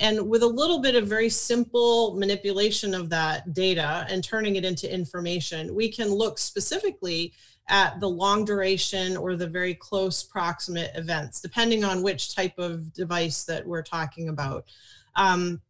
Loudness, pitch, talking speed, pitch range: -25 LUFS, 185 Hz, 160 wpm, 170-210 Hz